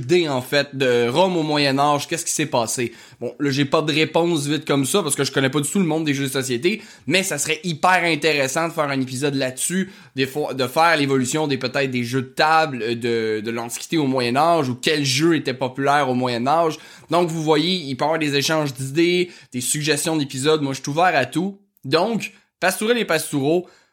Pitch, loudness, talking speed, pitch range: 150 Hz, -20 LUFS, 230 wpm, 135-165 Hz